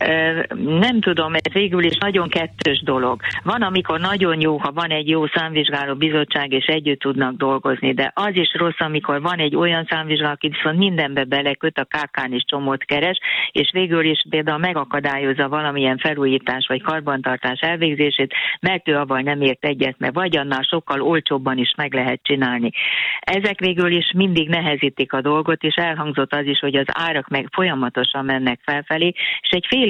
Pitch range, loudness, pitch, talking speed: 135-165 Hz, -19 LUFS, 150 Hz, 170 wpm